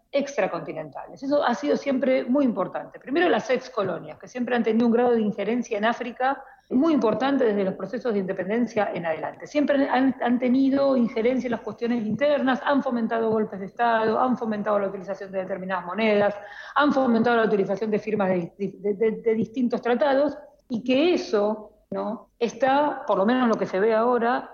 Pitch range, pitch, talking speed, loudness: 205-255 Hz, 230 Hz, 185 wpm, -24 LUFS